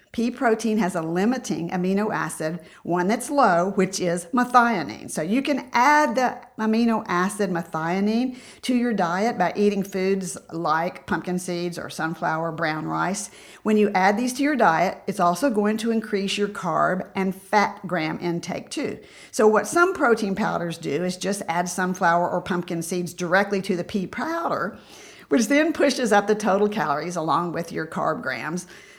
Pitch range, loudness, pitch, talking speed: 175-230 Hz, -23 LUFS, 195 Hz, 170 wpm